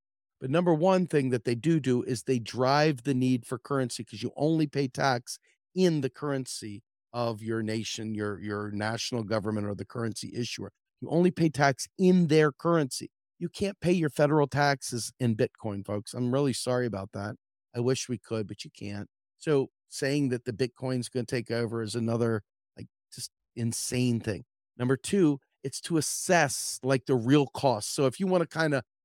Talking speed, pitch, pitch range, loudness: 190 wpm, 125 Hz, 115-145 Hz, -29 LUFS